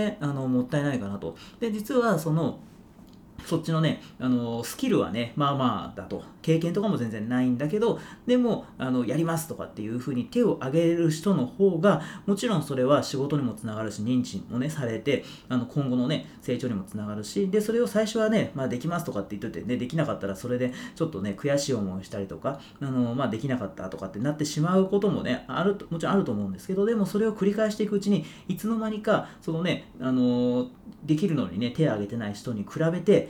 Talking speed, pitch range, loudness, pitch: 440 characters per minute, 120-195 Hz, -27 LUFS, 145 Hz